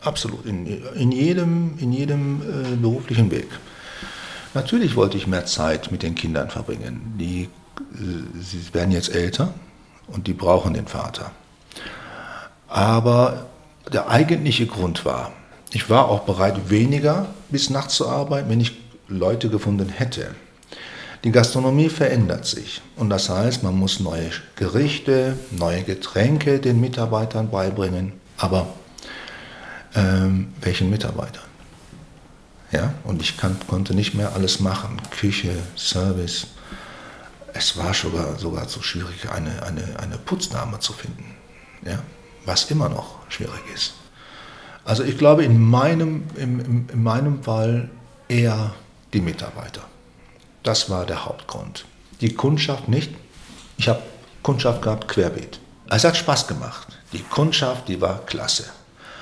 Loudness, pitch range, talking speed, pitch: -21 LUFS, 95-125 Hz, 130 wpm, 110 Hz